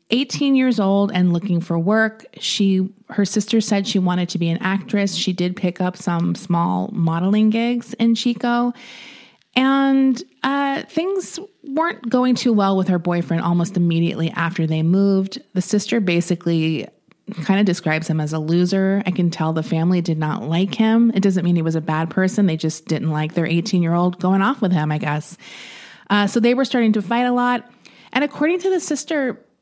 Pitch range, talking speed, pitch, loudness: 170-240 Hz, 195 wpm, 195 Hz, -19 LUFS